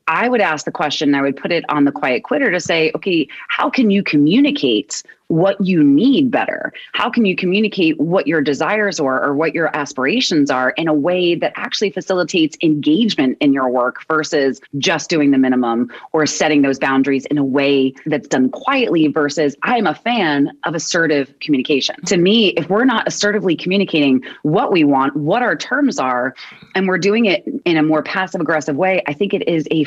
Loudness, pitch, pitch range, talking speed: -16 LUFS, 160 Hz, 145-200 Hz, 200 wpm